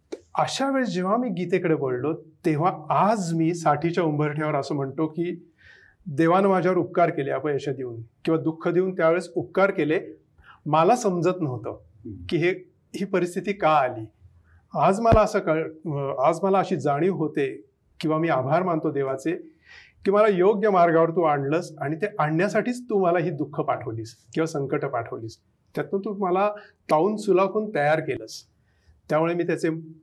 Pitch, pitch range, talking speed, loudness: 165 Hz, 145-185 Hz, 160 wpm, -24 LUFS